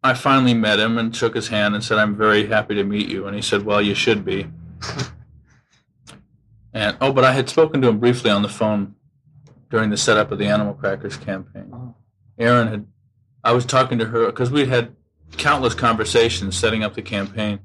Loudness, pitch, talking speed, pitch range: -19 LUFS, 110 Hz, 200 wpm, 105-125 Hz